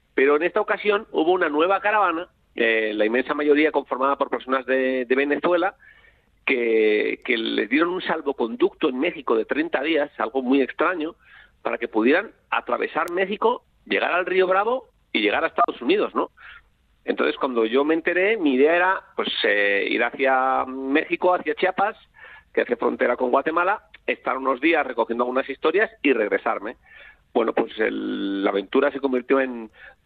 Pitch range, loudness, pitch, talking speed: 130-210 Hz, -22 LUFS, 155 Hz, 165 wpm